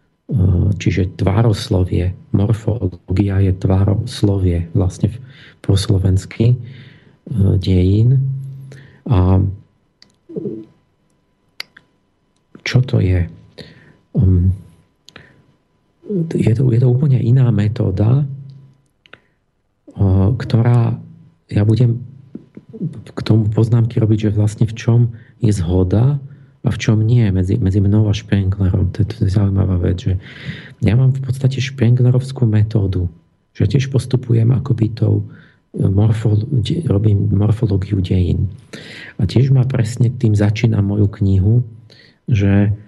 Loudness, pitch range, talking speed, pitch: -16 LUFS, 100-125 Hz, 100 wpm, 110 Hz